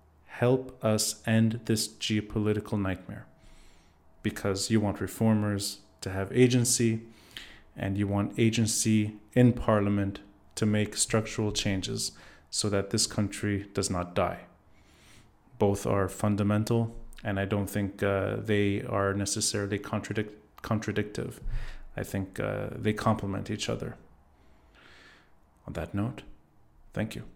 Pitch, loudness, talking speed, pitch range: 105 Hz, -29 LUFS, 120 wpm, 100-110 Hz